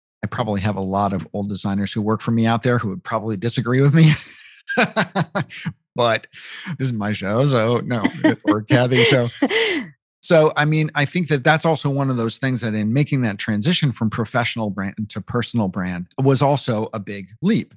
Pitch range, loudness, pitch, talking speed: 105-145 Hz, -19 LUFS, 120 Hz, 195 wpm